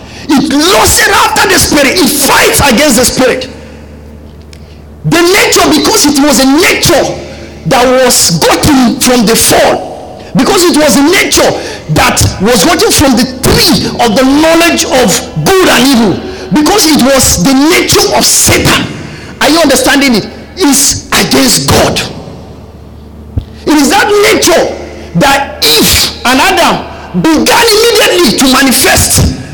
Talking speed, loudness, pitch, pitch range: 140 wpm, -6 LUFS, 280 Hz, 255-350 Hz